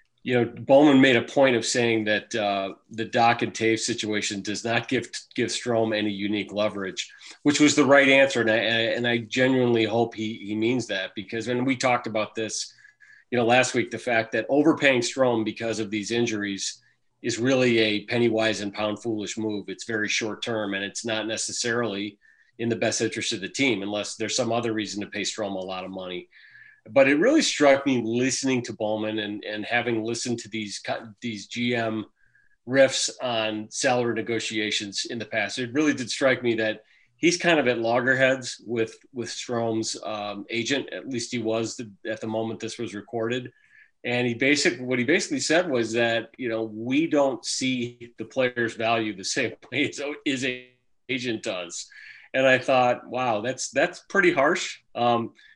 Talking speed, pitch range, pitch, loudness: 190 wpm, 110-125 Hz, 115 Hz, -24 LUFS